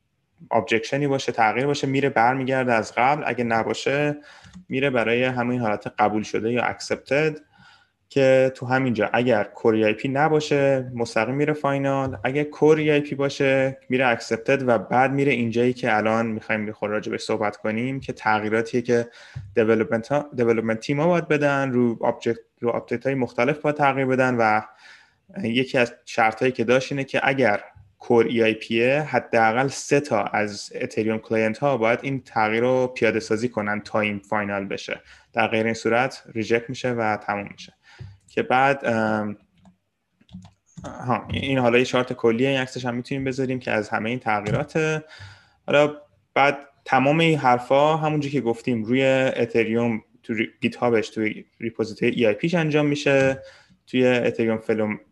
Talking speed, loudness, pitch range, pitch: 155 wpm, -22 LUFS, 110-135 Hz, 120 Hz